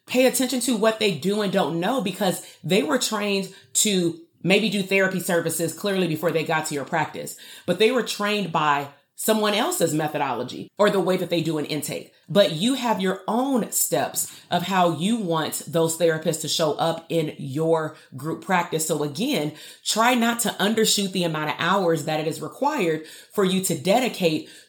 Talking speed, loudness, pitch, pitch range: 190 wpm, -23 LUFS, 180 Hz, 160-210 Hz